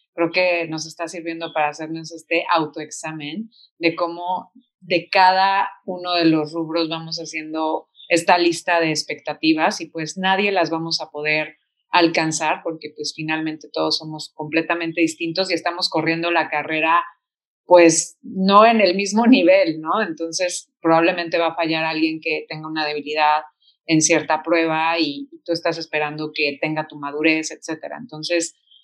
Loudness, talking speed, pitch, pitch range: -20 LUFS, 150 wpm, 165 Hz, 155-175 Hz